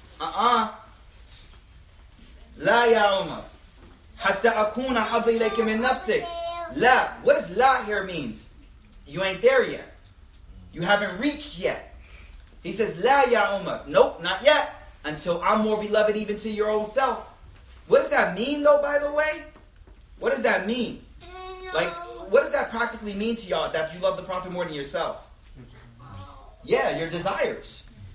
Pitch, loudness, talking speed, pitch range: 210 Hz, -24 LUFS, 140 wpm, 160-260 Hz